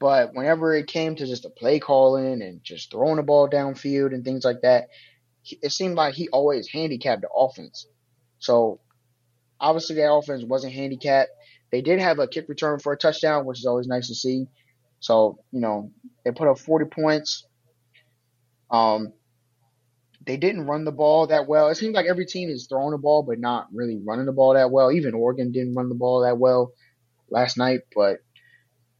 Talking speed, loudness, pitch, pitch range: 190 wpm, -22 LUFS, 130 Hz, 120-150 Hz